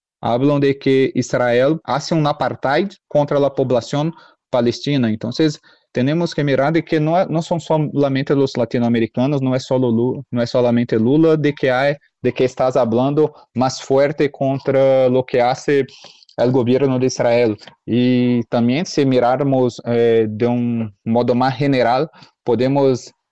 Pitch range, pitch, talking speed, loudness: 120-145 Hz, 130 Hz, 140 wpm, -17 LUFS